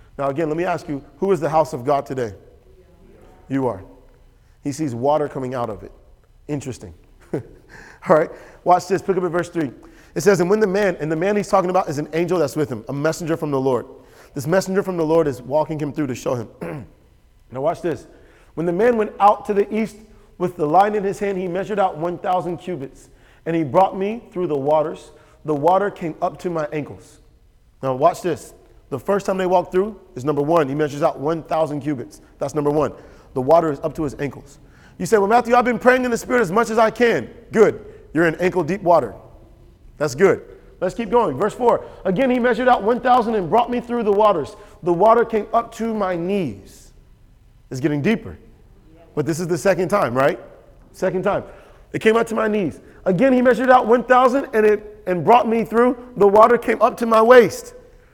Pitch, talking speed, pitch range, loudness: 180 Hz, 220 wpm, 150-215 Hz, -19 LUFS